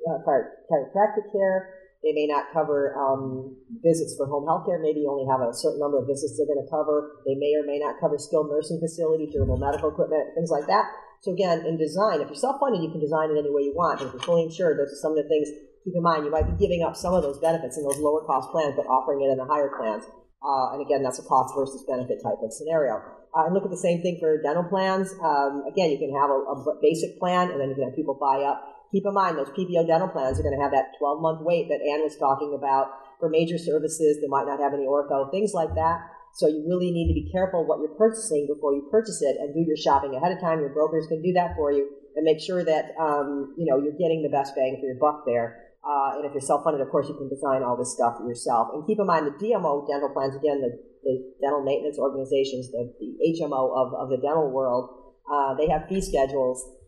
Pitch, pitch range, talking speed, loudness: 150 Hz, 140-165 Hz, 260 wpm, -25 LUFS